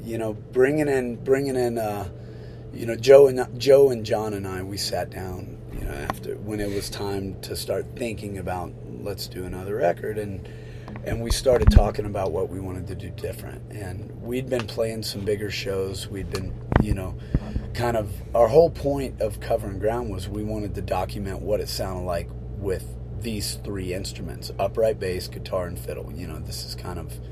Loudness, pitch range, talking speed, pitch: -25 LUFS, 100-115 Hz, 195 wpm, 105 Hz